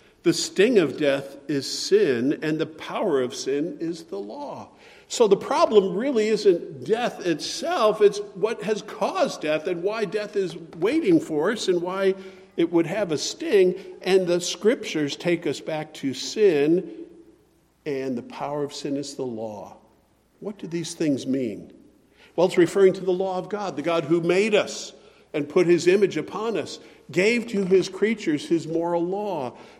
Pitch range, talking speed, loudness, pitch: 165-220 Hz, 175 wpm, -23 LUFS, 190 Hz